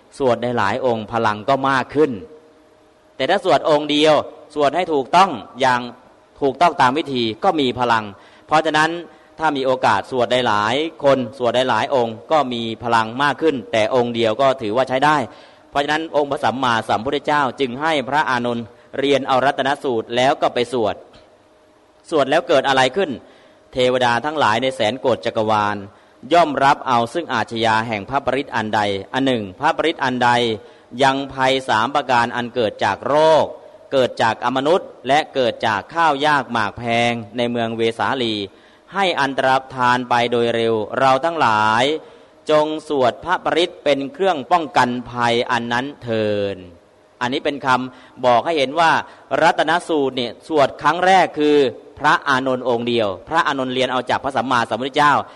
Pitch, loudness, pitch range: 130 Hz, -18 LUFS, 115-150 Hz